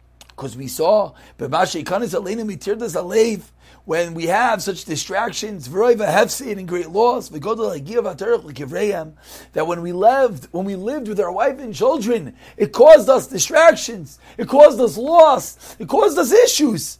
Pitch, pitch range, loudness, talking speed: 220 Hz, 180-280 Hz, -17 LUFS, 130 wpm